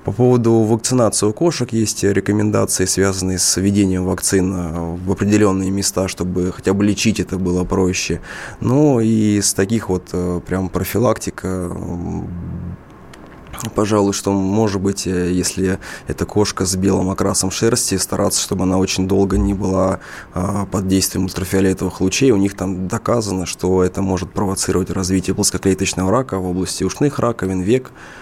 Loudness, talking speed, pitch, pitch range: -17 LUFS, 140 wpm, 95 Hz, 90-100 Hz